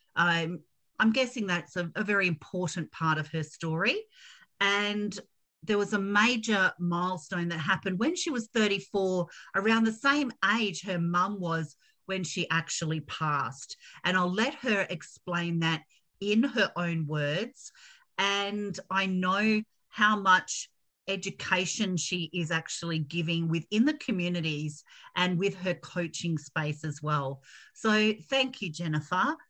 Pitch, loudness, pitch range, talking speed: 185 Hz, -29 LUFS, 170-210 Hz, 140 wpm